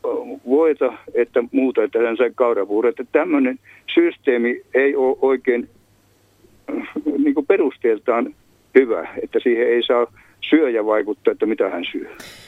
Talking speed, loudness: 120 wpm, -19 LUFS